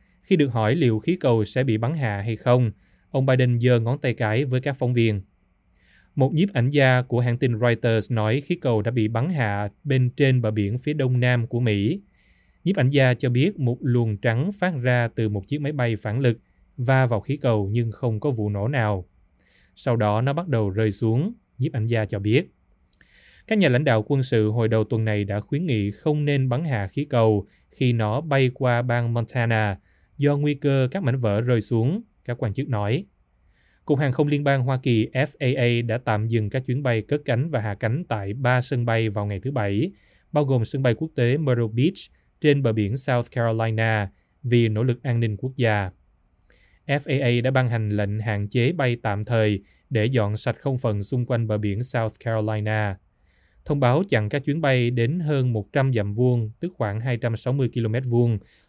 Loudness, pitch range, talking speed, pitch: -23 LUFS, 110-135 Hz, 210 wpm, 120 Hz